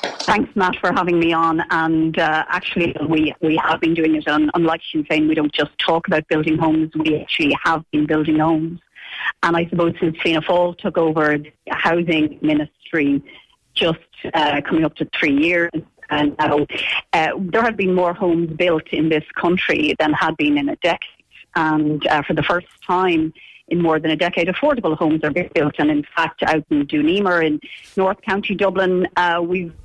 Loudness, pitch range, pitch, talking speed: -18 LUFS, 155-180 Hz, 165 Hz, 195 wpm